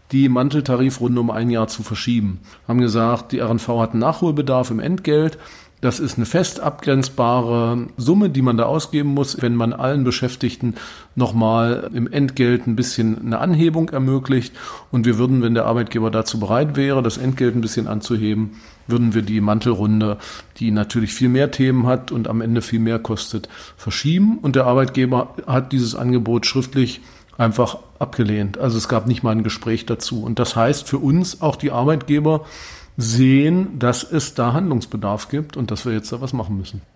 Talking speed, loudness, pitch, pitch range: 175 wpm, -19 LUFS, 120 Hz, 115-135 Hz